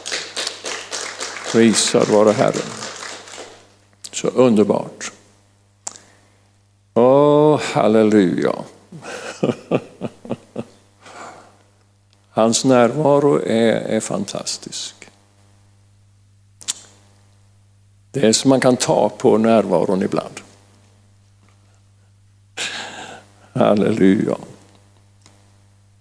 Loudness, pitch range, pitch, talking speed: -17 LUFS, 100-110 Hz, 100 Hz, 55 wpm